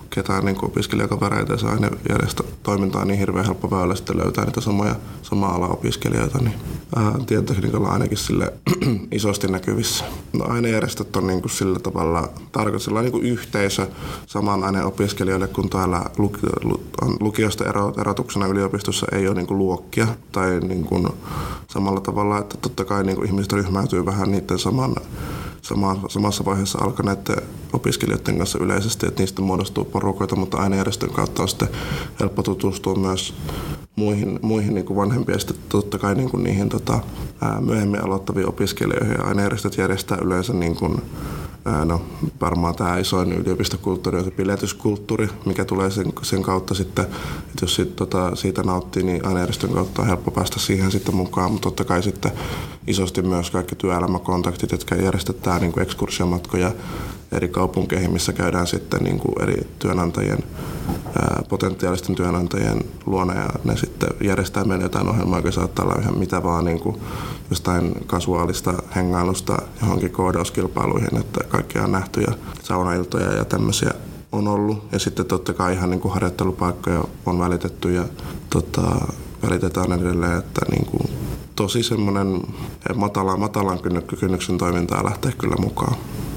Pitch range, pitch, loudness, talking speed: 90-105 Hz, 95 Hz, -22 LUFS, 150 wpm